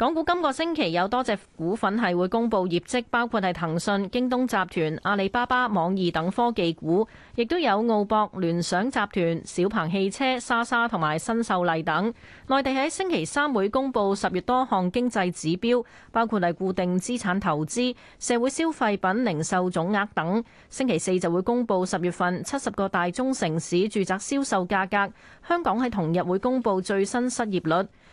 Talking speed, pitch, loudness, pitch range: 275 characters per minute, 200 Hz, -25 LUFS, 180-245 Hz